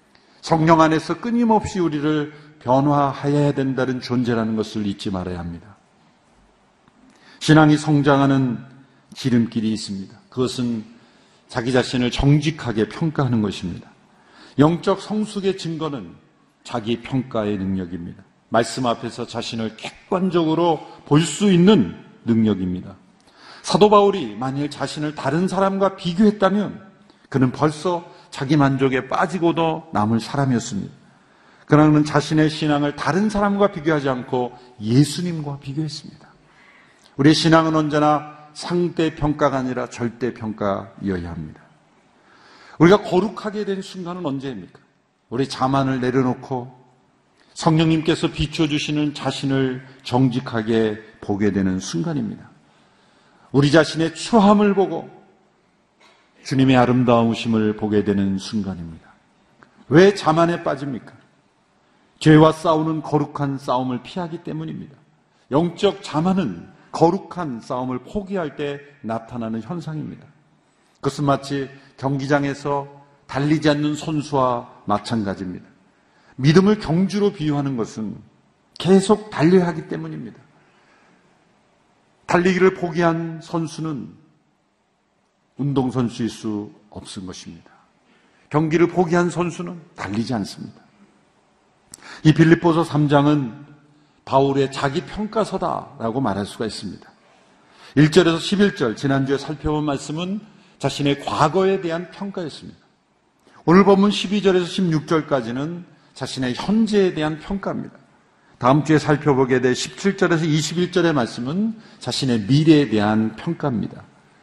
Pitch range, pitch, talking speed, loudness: 125-170 Hz, 150 Hz, 280 characters per minute, -20 LUFS